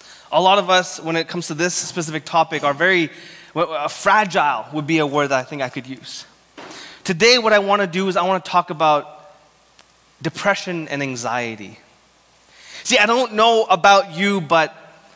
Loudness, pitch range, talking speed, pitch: -18 LUFS, 150-190 Hz, 185 wpm, 165 Hz